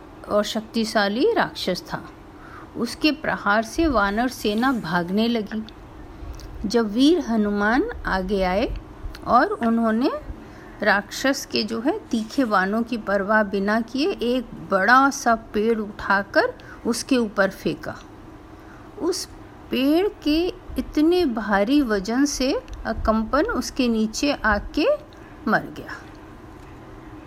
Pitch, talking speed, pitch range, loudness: 235 Hz, 110 wpm, 215-290 Hz, -22 LUFS